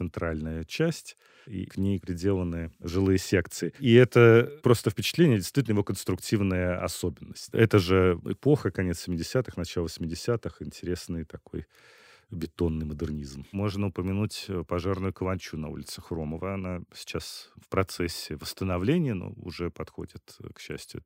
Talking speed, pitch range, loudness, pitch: 125 wpm, 85-105 Hz, -27 LUFS, 95 Hz